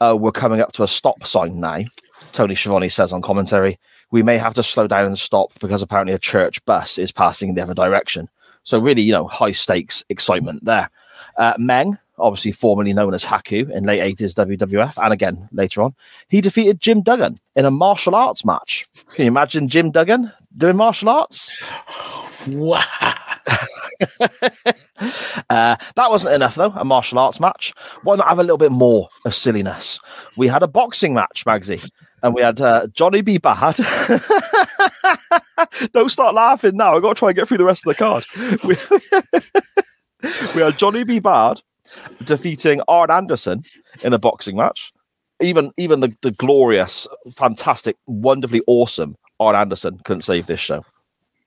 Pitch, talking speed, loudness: 155 Hz, 175 wpm, -16 LUFS